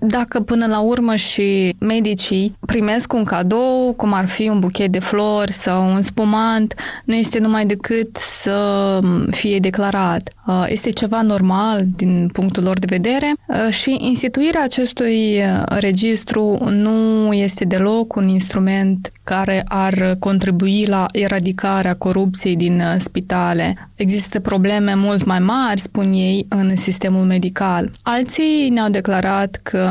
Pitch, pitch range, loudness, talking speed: 200 Hz, 190-220 Hz, -17 LUFS, 130 wpm